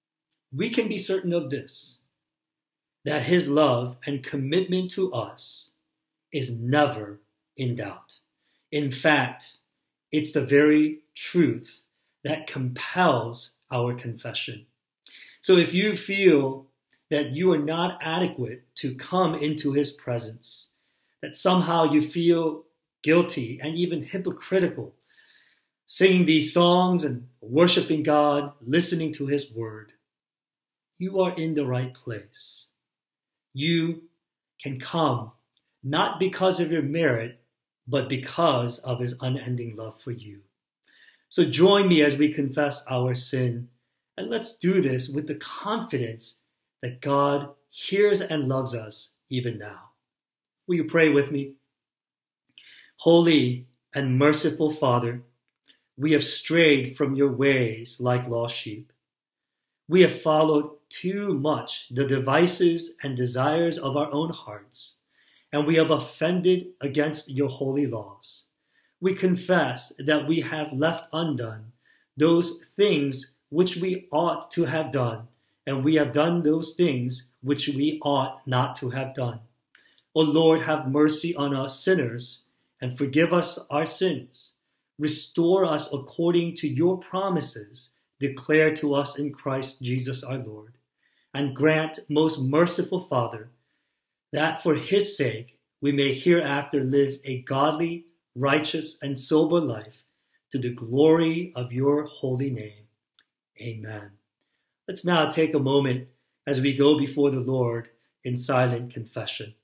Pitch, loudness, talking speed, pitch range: 145 Hz, -24 LUFS, 130 wpm, 130-165 Hz